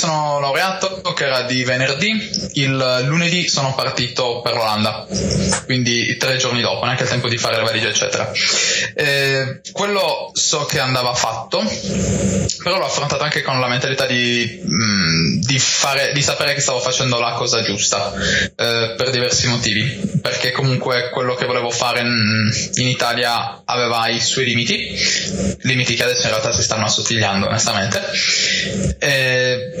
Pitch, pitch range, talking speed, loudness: 125 Hz, 120-135 Hz, 150 wpm, -17 LUFS